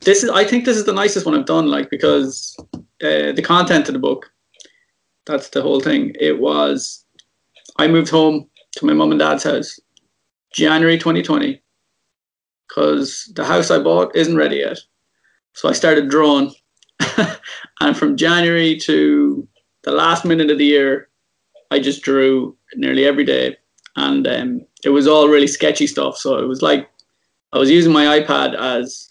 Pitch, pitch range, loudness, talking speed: 155 Hz, 140-195 Hz, -15 LUFS, 170 wpm